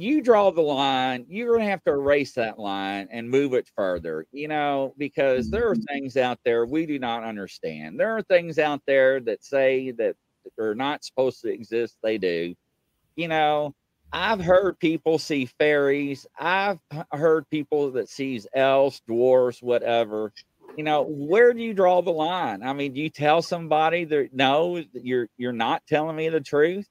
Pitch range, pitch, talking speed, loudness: 125-160 Hz, 140 Hz, 180 wpm, -24 LUFS